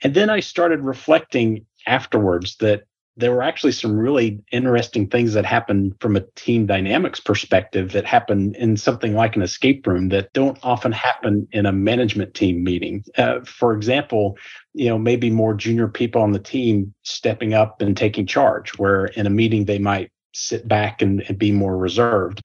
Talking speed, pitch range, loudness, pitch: 180 wpm, 100-120 Hz, -19 LUFS, 110 Hz